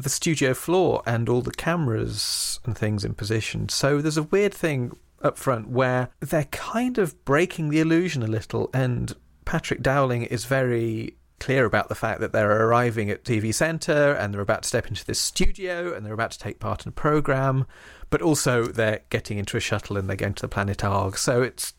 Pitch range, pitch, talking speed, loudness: 110-150 Hz, 125 Hz, 205 wpm, -24 LUFS